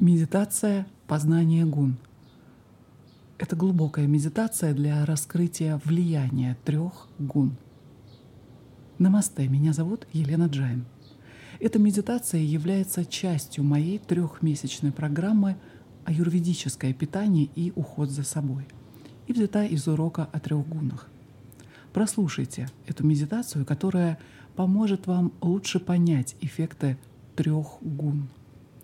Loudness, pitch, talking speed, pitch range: -26 LUFS, 155 Hz, 100 wpm, 135-175 Hz